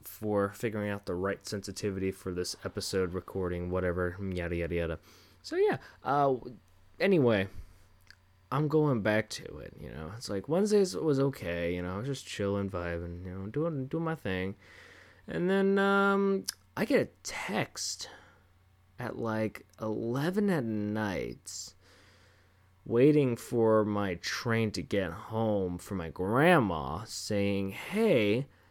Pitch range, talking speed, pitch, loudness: 95-120 Hz, 145 wpm, 100 Hz, -31 LUFS